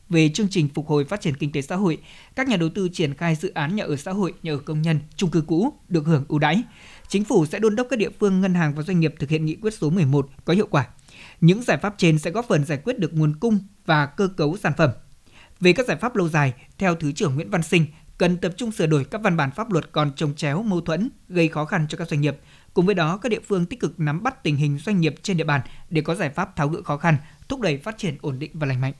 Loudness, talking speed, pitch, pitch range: -22 LUFS, 290 wpm, 165 Hz, 150-190 Hz